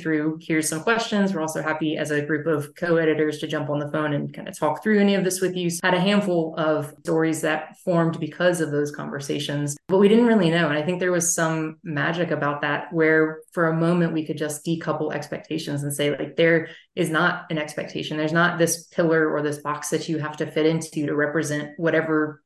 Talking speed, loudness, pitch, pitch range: 230 wpm, -23 LUFS, 160 Hz, 150-170 Hz